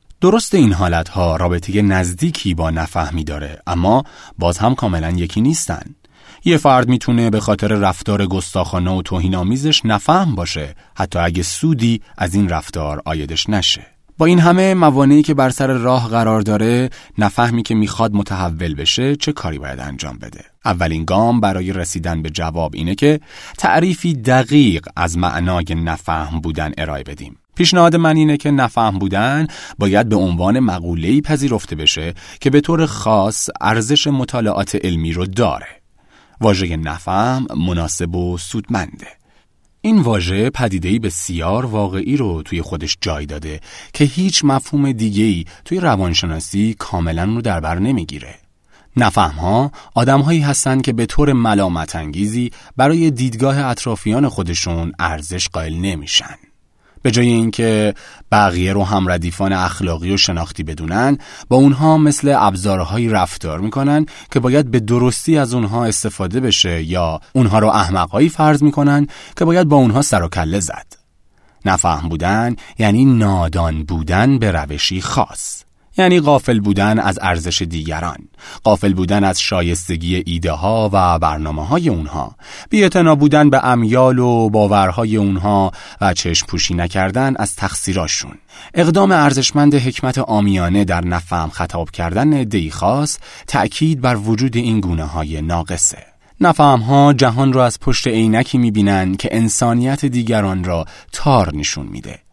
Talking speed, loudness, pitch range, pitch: 140 wpm, -15 LUFS, 85-130 Hz, 105 Hz